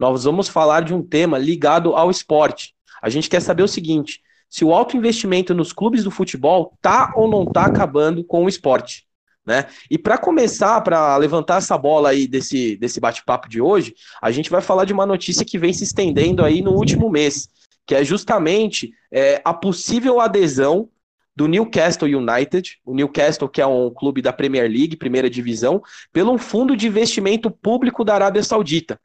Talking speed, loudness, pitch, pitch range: 185 wpm, -17 LUFS, 175 Hz, 145-205 Hz